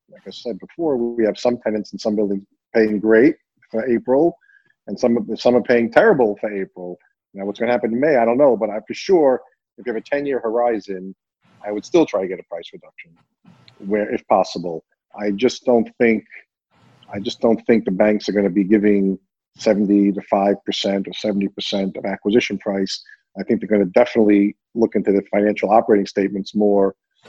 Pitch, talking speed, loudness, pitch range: 105 Hz, 210 wpm, -19 LUFS, 100-115 Hz